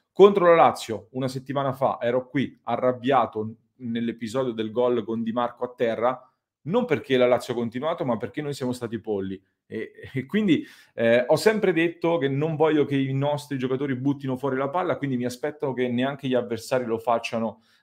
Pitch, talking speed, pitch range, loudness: 130 Hz, 190 wpm, 115-145 Hz, -24 LUFS